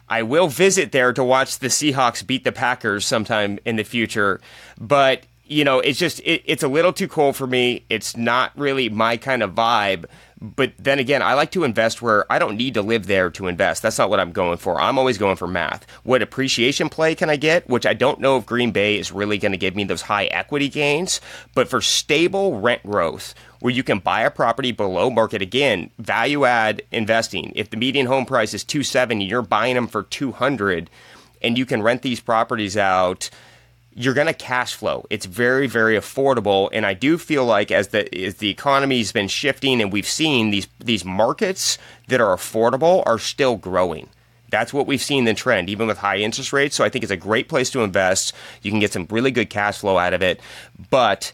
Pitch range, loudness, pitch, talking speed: 105-135 Hz, -19 LUFS, 120 Hz, 220 wpm